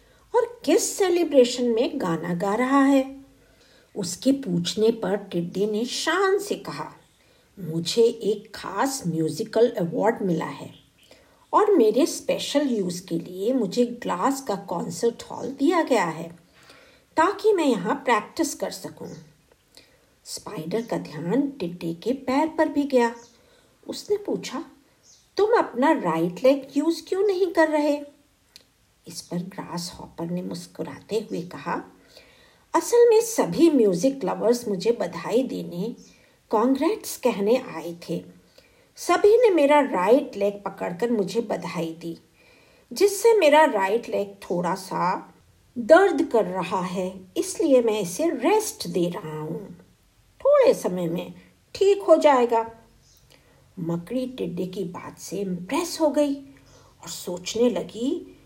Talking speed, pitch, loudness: 130 wpm, 235 Hz, -23 LUFS